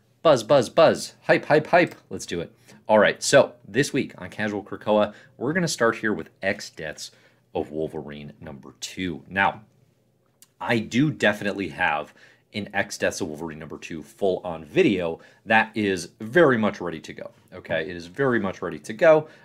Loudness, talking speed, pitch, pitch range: -23 LUFS, 180 wpm, 100 Hz, 85-115 Hz